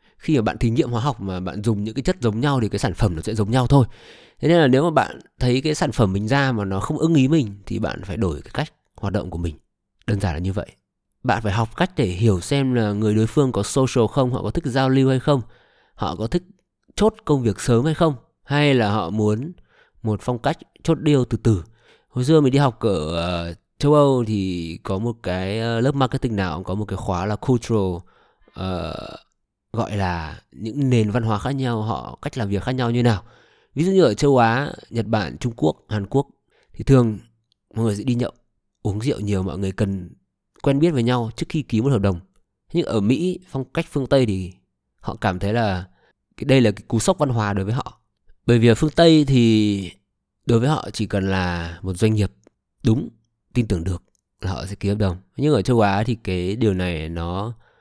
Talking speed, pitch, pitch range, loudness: 240 wpm, 115 Hz, 100-135 Hz, -21 LUFS